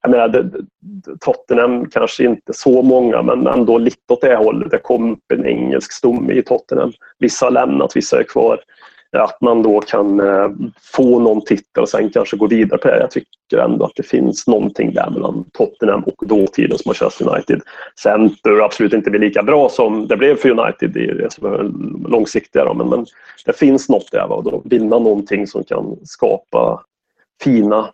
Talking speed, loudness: 175 wpm, -14 LUFS